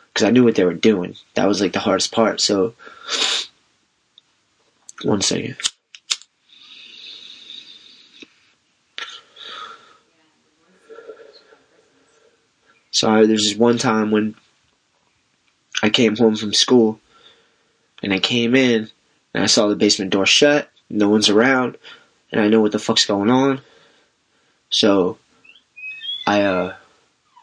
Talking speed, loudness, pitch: 115 wpm, -17 LUFS, 115 Hz